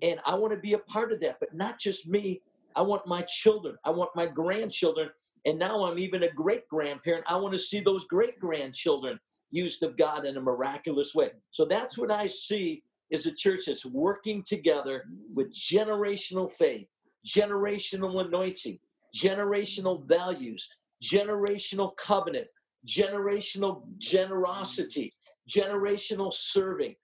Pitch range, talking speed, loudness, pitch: 175-215 Hz, 145 wpm, -29 LUFS, 200 Hz